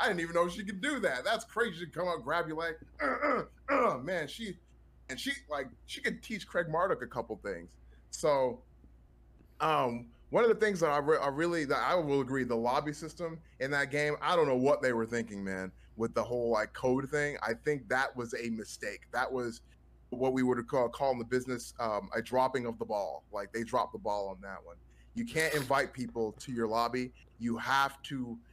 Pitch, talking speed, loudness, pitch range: 130 Hz, 225 wpm, -33 LUFS, 115-160 Hz